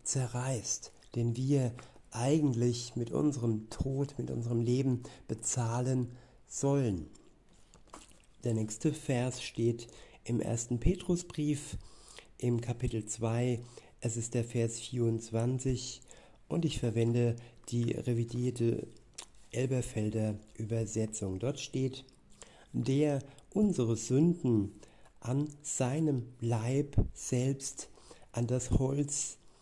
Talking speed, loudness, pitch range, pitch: 95 wpm, -34 LUFS, 115-135 Hz, 125 Hz